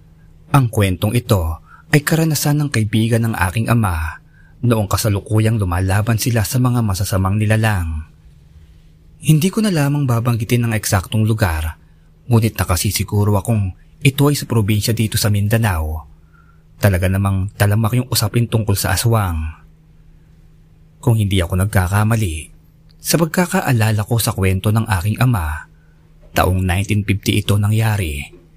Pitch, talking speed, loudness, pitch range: 105 Hz, 125 wpm, -17 LUFS, 95-115 Hz